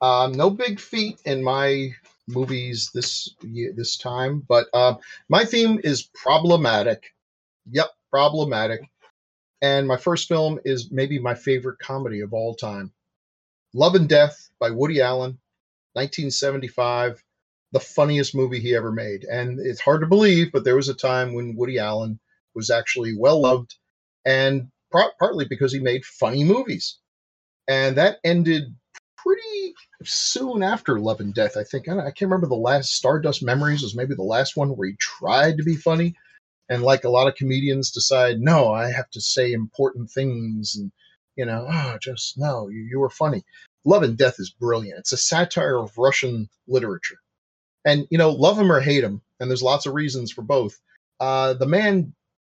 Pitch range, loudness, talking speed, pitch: 120-150 Hz, -21 LUFS, 170 wpm, 130 Hz